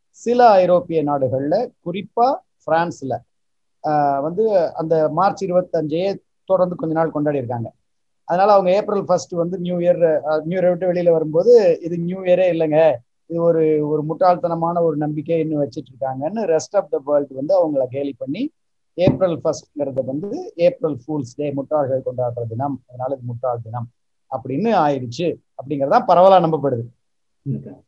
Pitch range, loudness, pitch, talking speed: 140-180 Hz, -19 LUFS, 160 Hz, 140 wpm